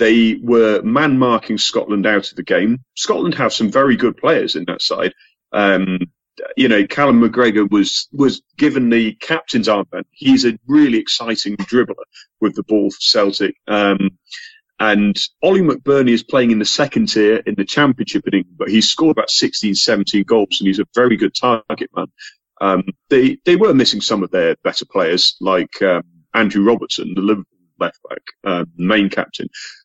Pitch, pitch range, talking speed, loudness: 110 Hz, 100-125 Hz, 175 wpm, -15 LUFS